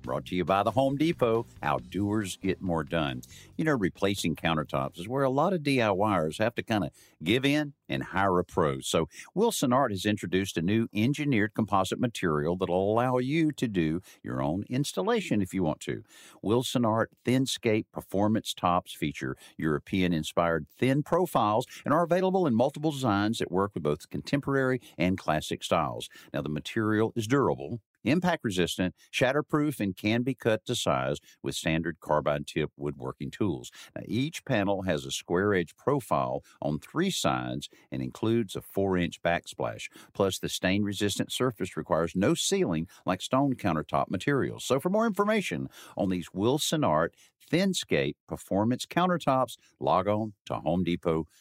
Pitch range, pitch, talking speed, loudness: 85-130 Hz, 105 Hz, 165 wpm, -29 LUFS